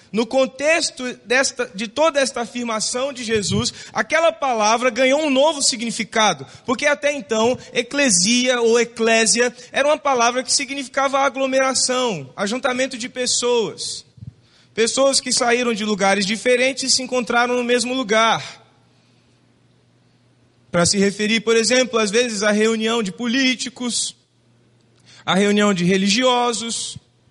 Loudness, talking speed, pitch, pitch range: -18 LUFS, 125 wpm, 245 Hz, 220-265 Hz